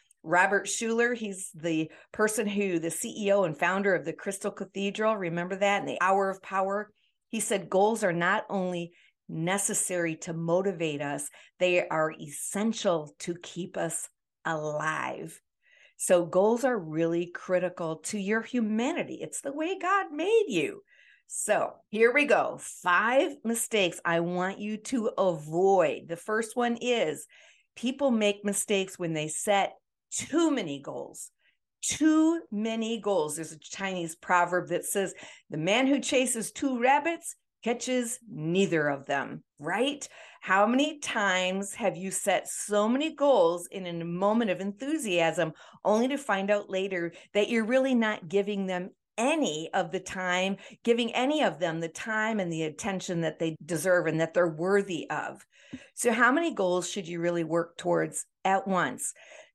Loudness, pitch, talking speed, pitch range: -28 LUFS, 195 Hz, 155 wpm, 175-235 Hz